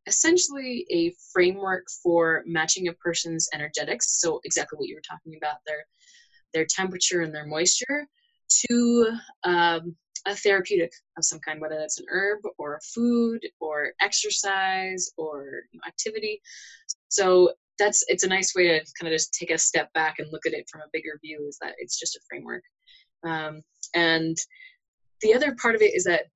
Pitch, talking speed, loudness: 185 Hz, 180 wpm, -24 LUFS